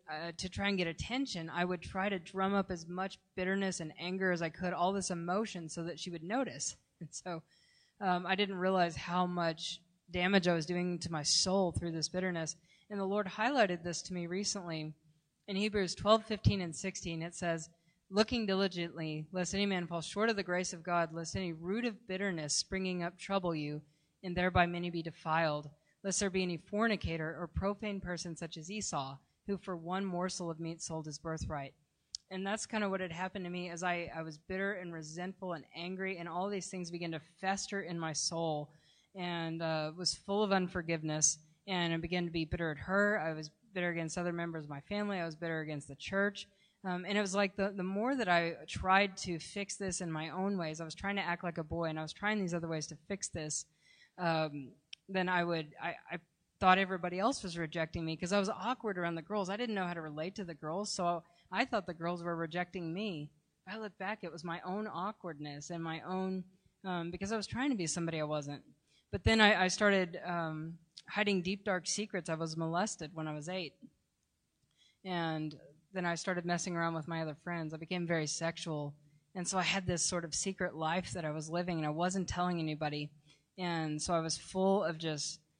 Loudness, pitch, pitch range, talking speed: -36 LUFS, 175 Hz, 165-190 Hz, 220 wpm